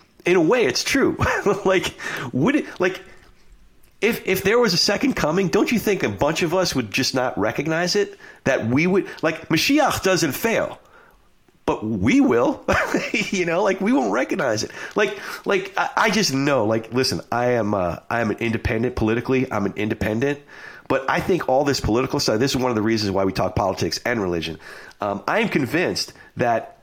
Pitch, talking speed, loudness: 145 Hz, 195 wpm, -21 LUFS